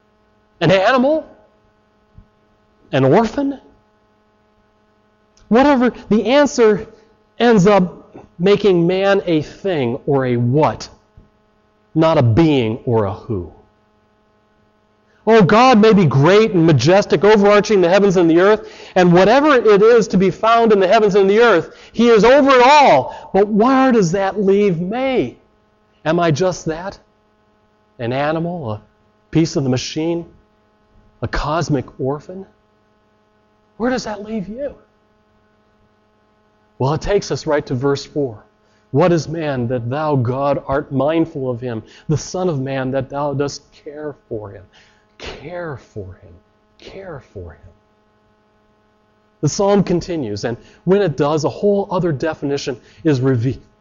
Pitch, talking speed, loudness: 140 Hz, 140 wpm, -15 LUFS